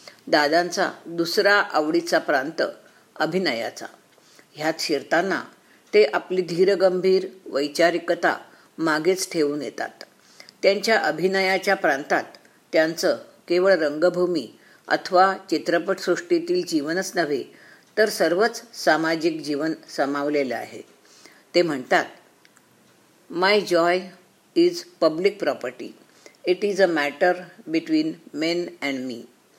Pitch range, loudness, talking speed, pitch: 165-205 Hz, -22 LUFS, 90 wpm, 180 Hz